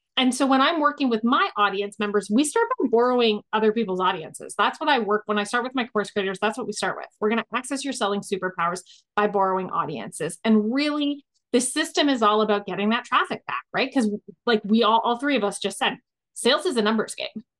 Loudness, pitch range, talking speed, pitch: -23 LUFS, 205-260 Hz, 235 wpm, 220 Hz